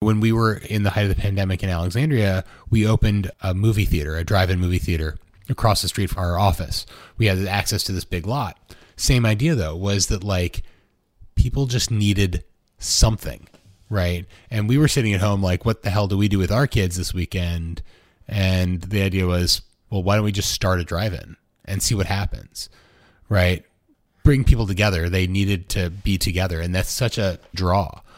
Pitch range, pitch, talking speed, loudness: 90-105 Hz, 95 Hz, 200 wpm, -21 LUFS